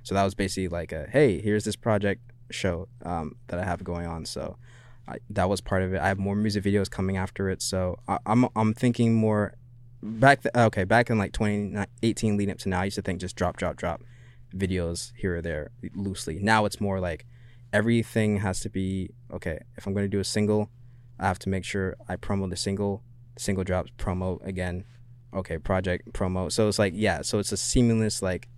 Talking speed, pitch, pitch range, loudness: 215 wpm, 100 Hz, 95-115 Hz, -27 LUFS